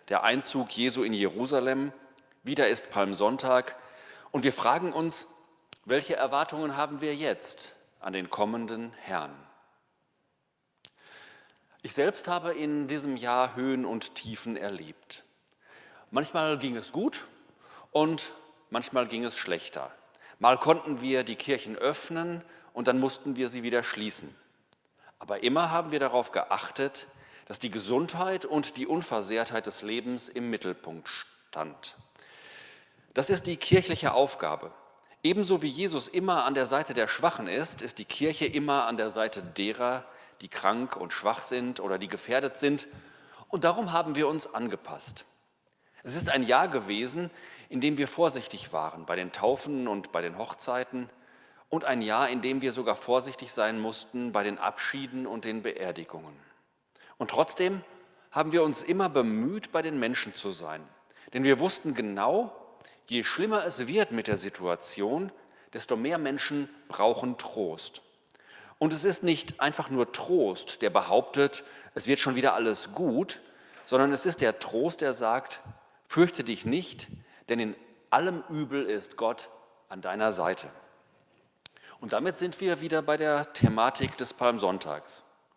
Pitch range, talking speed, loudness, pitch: 115-155 Hz, 150 wpm, -29 LUFS, 135 Hz